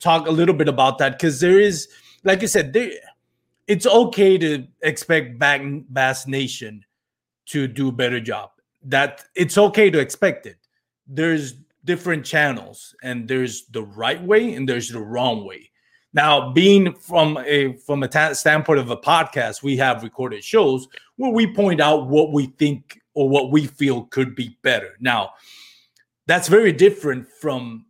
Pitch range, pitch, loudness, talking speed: 130-170 Hz, 145 Hz, -19 LUFS, 165 wpm